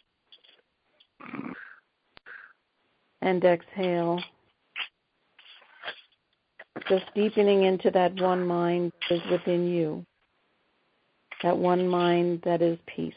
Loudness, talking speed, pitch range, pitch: -26 LUFS, 80 wpm, 175-185 Hz, 175 Hz